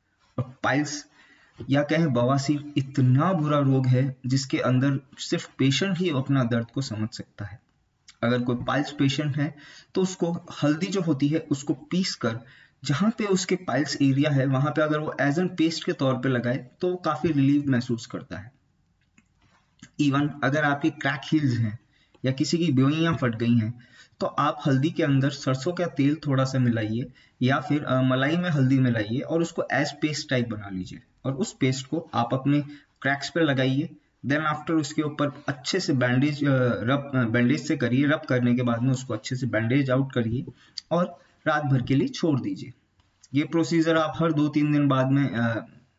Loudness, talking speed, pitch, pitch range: -25 LUFS, 185 wpm, 140 Hz, 125-155 Hz